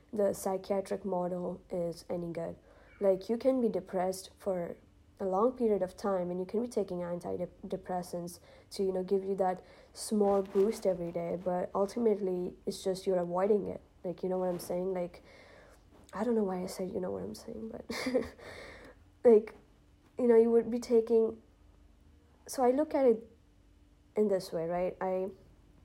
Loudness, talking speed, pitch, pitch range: -32 LUFS, 175 wpm, 190 Hz, 180-215 Hz